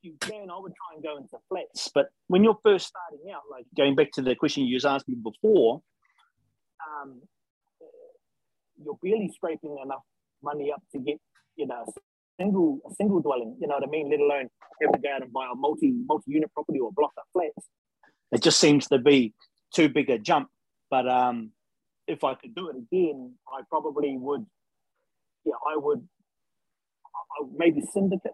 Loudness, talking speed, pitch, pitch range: -26 LUFS, 190 wpm, 155 Hz, 140-210 Hz